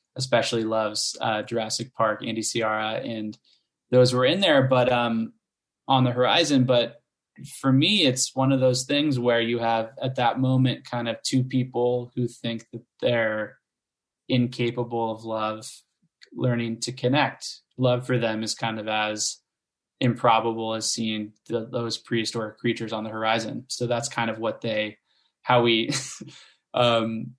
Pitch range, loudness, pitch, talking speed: 110-125 Hz, -24 LUFS, 120 Hz, 155 wpm